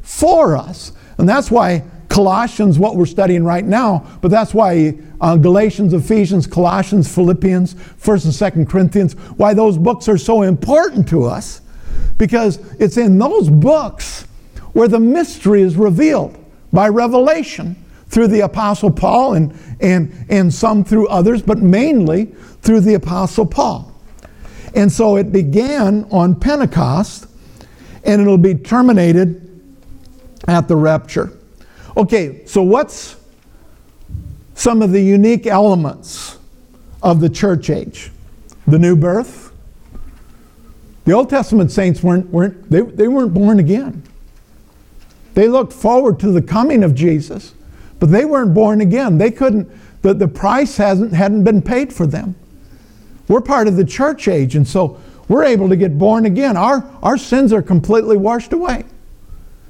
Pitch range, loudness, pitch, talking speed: 175-220 Hz, -13 LUFS, 200 Hz, 145 wpm